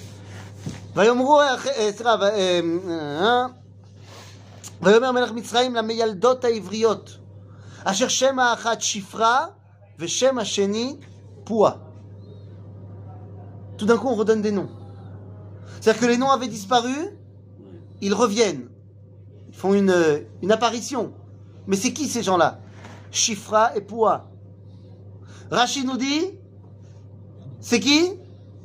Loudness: -21 LUFS